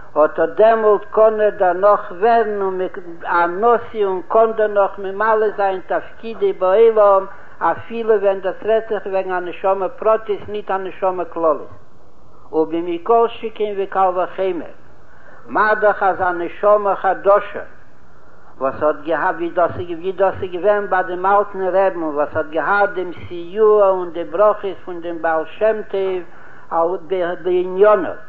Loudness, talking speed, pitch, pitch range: -17 LUFS, 130 wpm, 190 Hz, 175-210 Hz